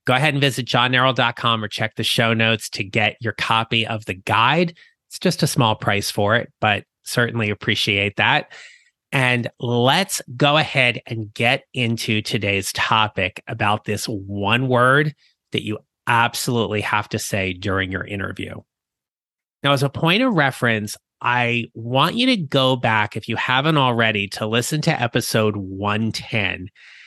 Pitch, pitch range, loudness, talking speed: 115 Hz, 105-130 Hz, -19 LUFS, 155 wpm